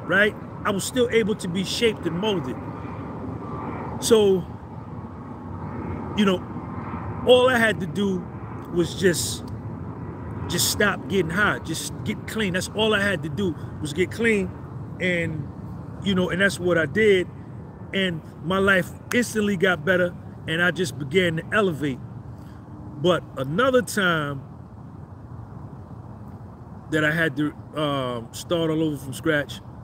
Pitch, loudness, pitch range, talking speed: 155 Hz, -23 LUFS, 120-185 Hz, 140 wpm